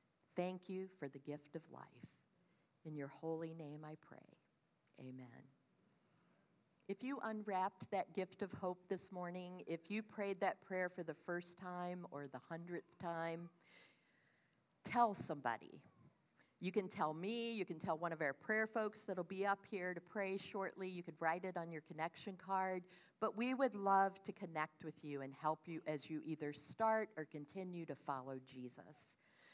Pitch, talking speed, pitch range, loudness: 180 Hz, 175 wpm, 155-195 Hz, -45 LUFS